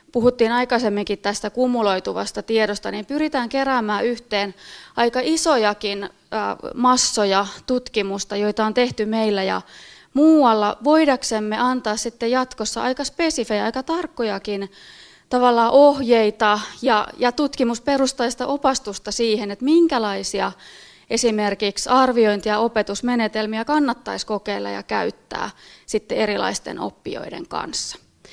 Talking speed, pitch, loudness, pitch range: 100 wpm, 230 Hz, -20 LUFS, 210-255 Hz